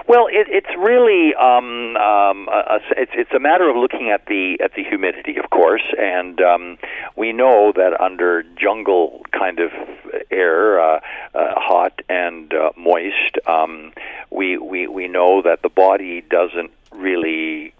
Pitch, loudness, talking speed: 110 Hz, -16 LUFS, 155 wpm